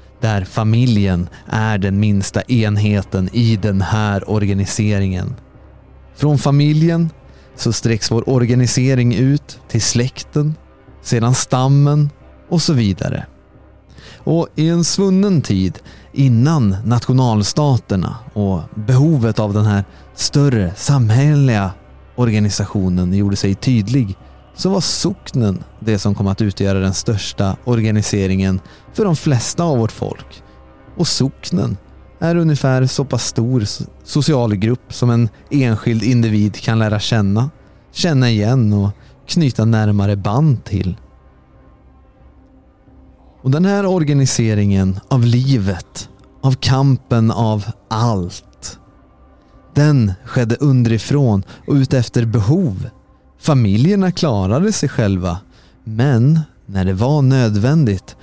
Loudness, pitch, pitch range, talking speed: -16 LUFS, 115 Hz, 100-135 Hz, 110 wpm